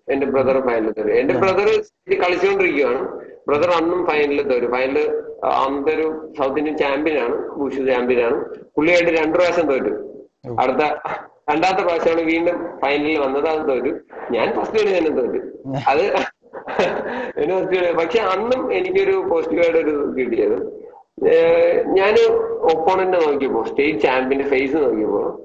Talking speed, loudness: 120 wpm, -18 LUFS